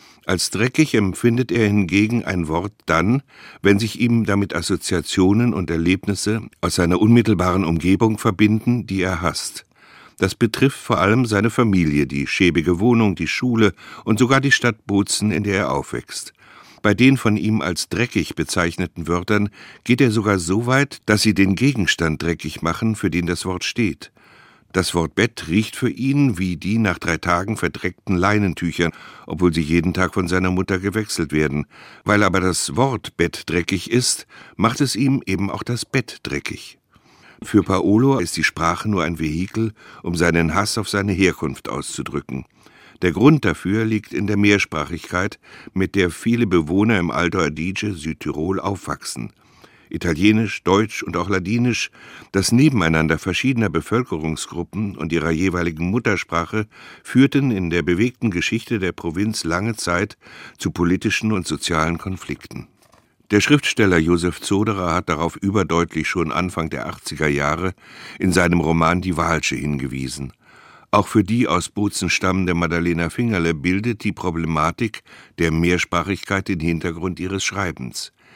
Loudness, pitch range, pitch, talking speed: -19 LUFS, 85-110 Hz, 95 Hz, 150 wpm